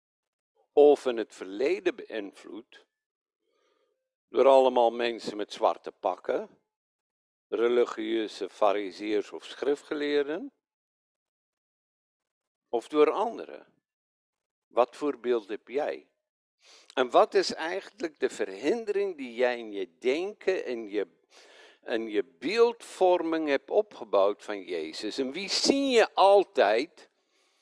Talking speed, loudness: 105 wpm, -28 LUFS